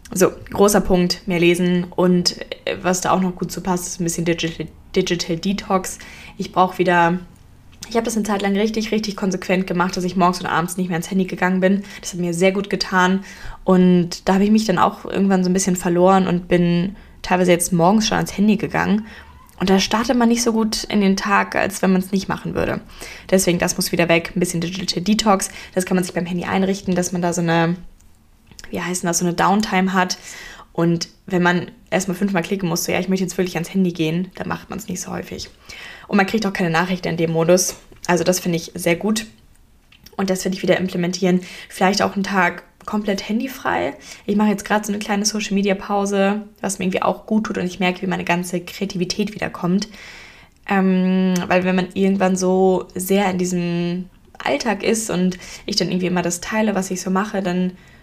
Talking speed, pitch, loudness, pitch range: 215 wpm, 185 Hz, -19 LUFS, 175-195 Hz